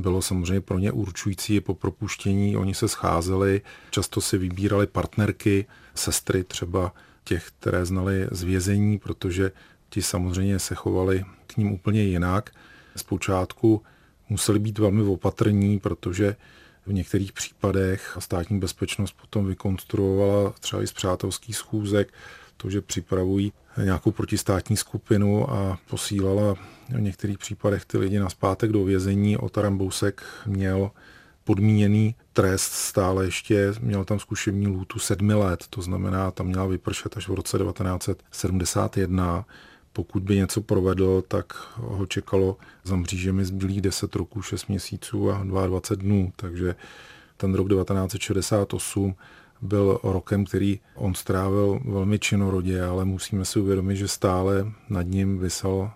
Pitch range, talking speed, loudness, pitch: 95-105 Hz, 135 wpm, -25 LUFS, 100 Hz